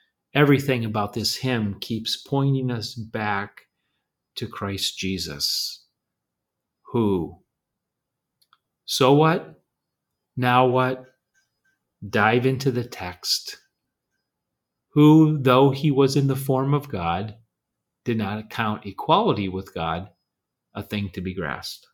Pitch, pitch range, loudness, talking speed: 120 Hz, 105-135 Hz, -22 LUFS, 110 wpm